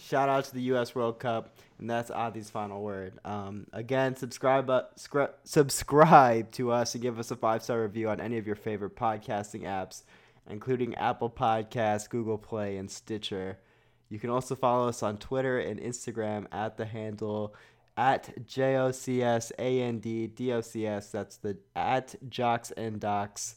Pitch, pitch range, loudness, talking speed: 115 Hz, 105-125 Hz, -30 LUFS, 145 wpm